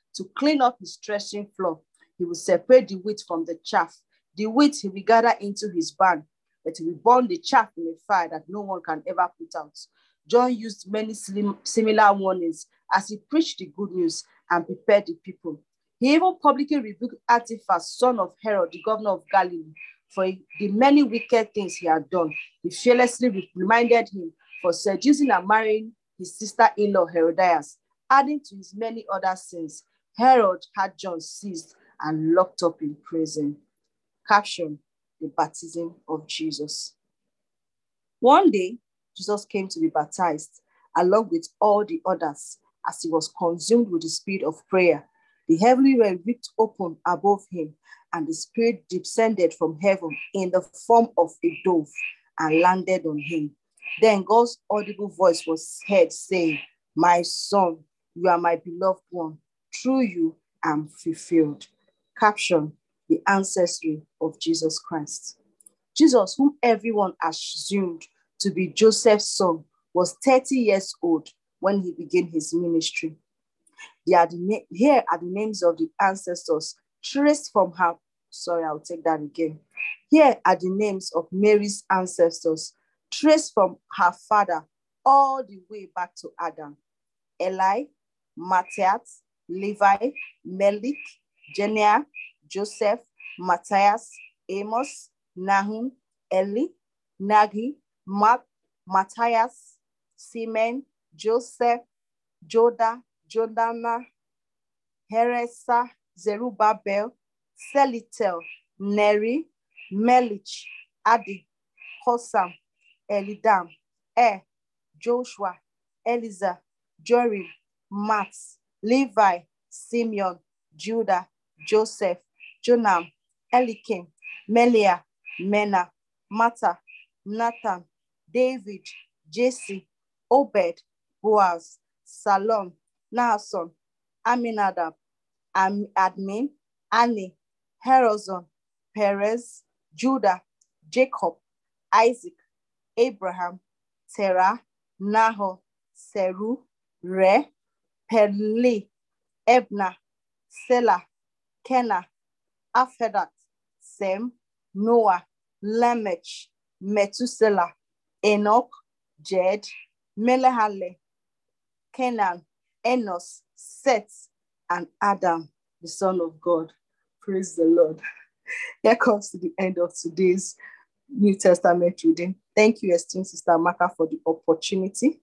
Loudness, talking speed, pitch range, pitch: -23 LUFS, 115 wpm, 175-230 Hz, 195 Hz